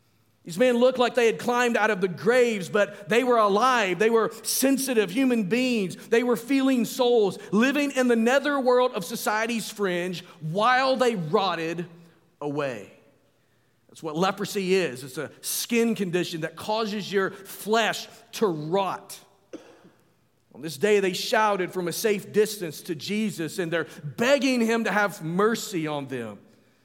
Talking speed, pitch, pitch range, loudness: 155 wpm, 210 Hz, 175-235 Hz, -24 LUFS